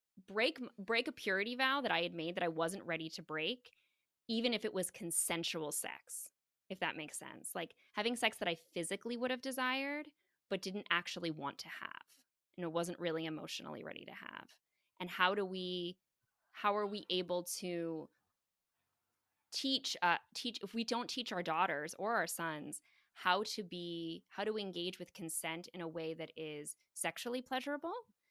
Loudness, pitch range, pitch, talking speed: -39 LUFS, 170-230 Hz, 180 Hz, 180 wpm